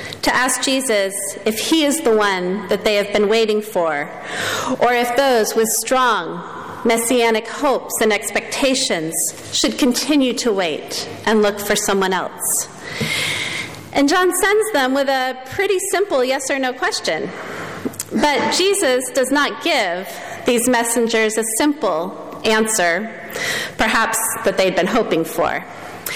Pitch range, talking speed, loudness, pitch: 215-270 Hz, 140 wpm, -18 LUFS, 230 Hz